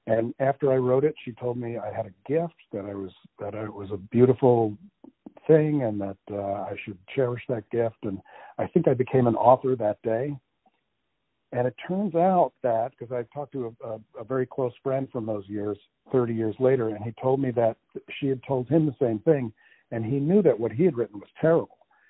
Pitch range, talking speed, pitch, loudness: 110-135 Hz, 225 wpm, 125 Hz, -26 LUFS